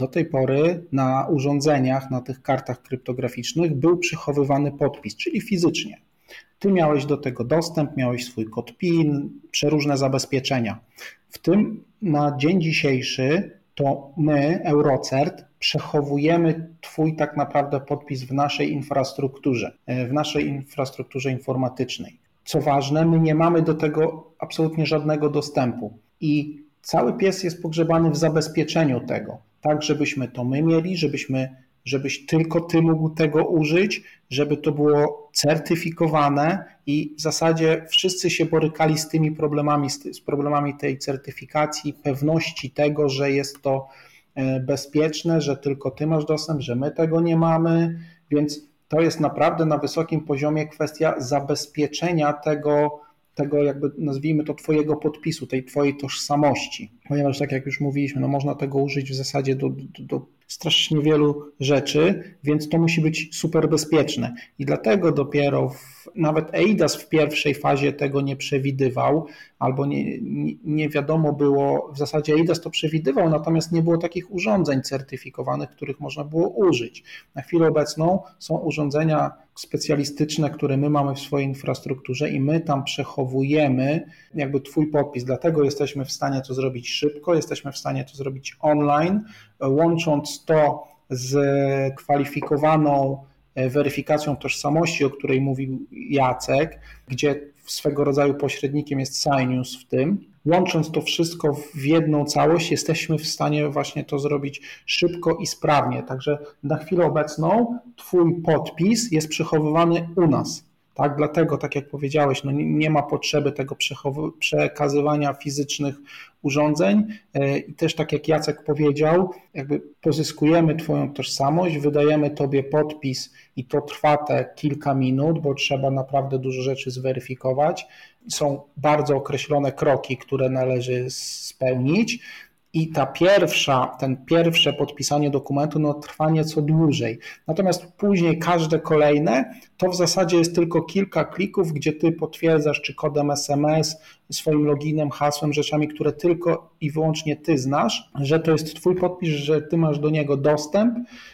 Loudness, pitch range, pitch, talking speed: -22 LUFS, 140-160 Hz, 150 Hz, 140 wpm